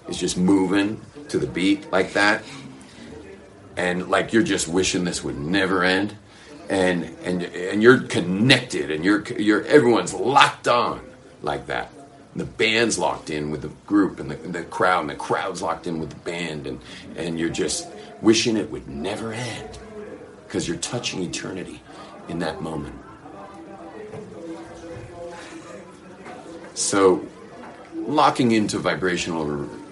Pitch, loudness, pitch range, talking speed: 95 Hz, -22 LUFS, 85-110 Hz, 140 wpm